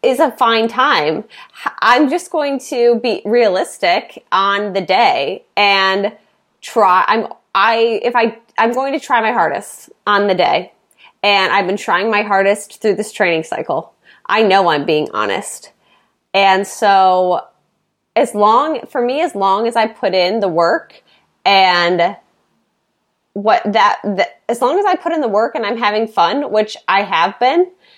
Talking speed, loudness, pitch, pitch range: 165 wpm, -14 LUFS, 210 Hz, 195-240 Hz